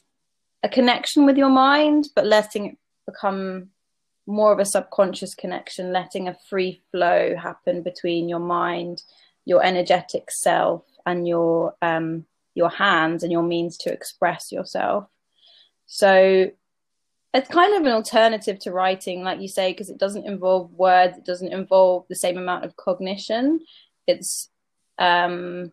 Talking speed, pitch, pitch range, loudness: 145 wpm, 185 Hz, 180-210 Hz, -21 LUFS